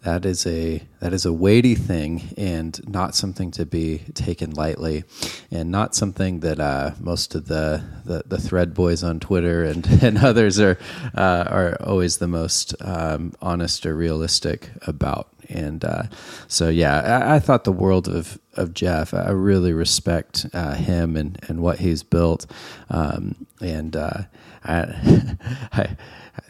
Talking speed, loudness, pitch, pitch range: 160 wpm, -21 LUFS, 85 Hz, 80-95 Hz